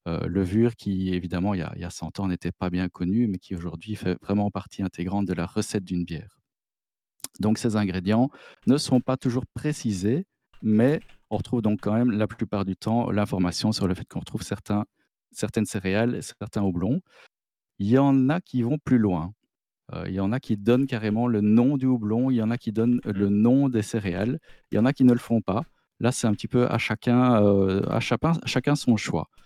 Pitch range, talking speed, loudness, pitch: 95-120 Hz, 225 wpm, -25 LUFS, 110 Hz